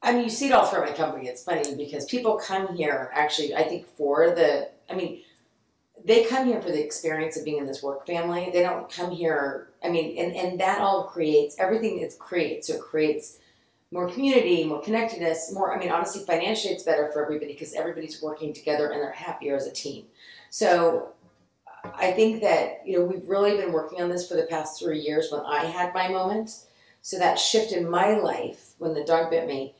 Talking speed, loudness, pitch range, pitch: 215 wpm, -26 LUFS, 155-195 Hz, 170 Hz